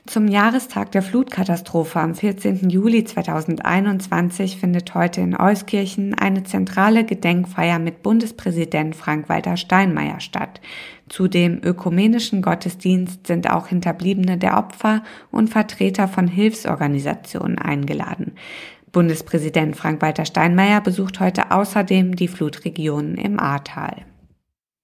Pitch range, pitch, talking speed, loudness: 165-200 Hz, 185 Hz, 105 wpm, -19 LUFS